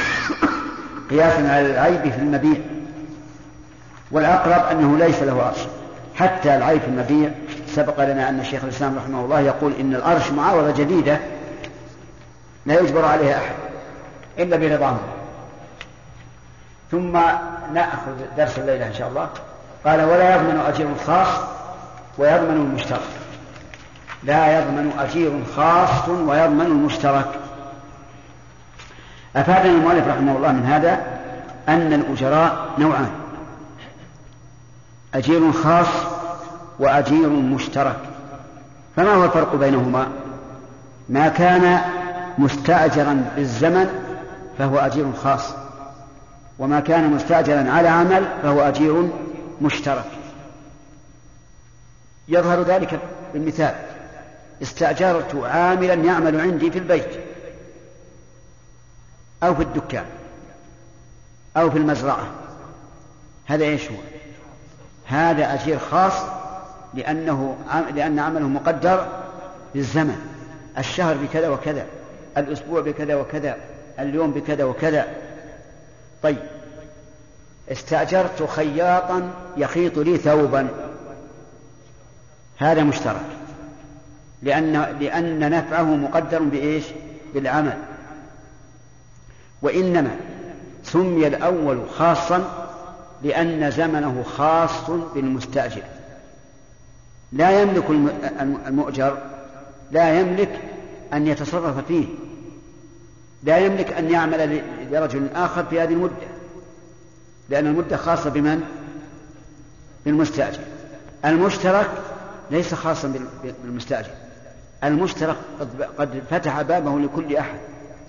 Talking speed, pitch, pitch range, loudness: 90 wpm, 150 Hz, 140-165 Hz, -19 LUFS